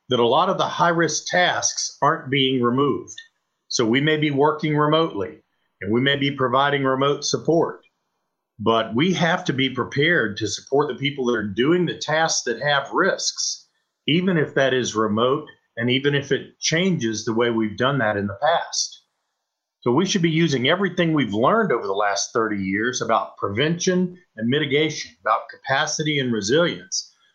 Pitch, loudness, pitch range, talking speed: 140 Hz, -21 LUFS, 120-160 Hz, 180 wpm